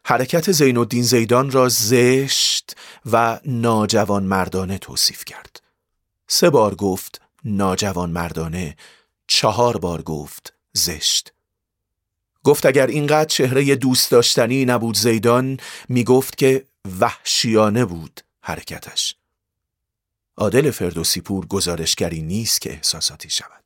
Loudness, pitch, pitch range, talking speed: -18 LUFS, 115 Hz, 95-125 Hz, 100 wpm